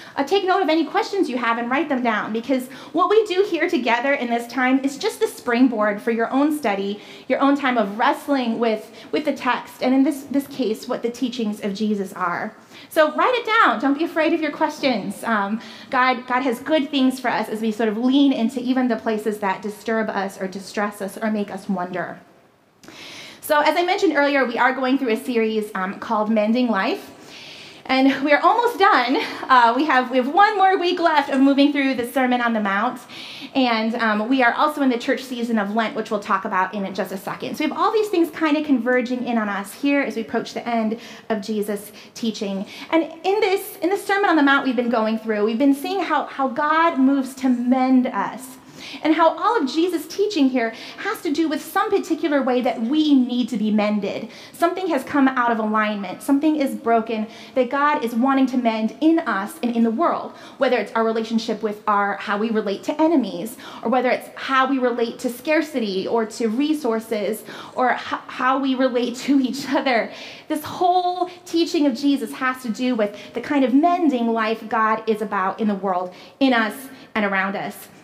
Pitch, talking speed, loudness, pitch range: 255 Hz, 215 wpm, -20 LUFS, 220-295 Hz